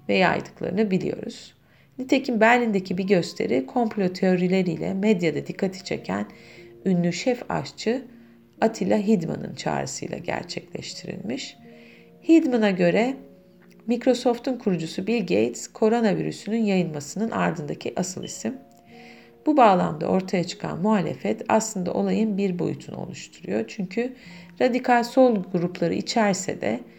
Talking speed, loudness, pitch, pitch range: 100 wpm, -24 LUFS, 195 Hz, 180-235 Hz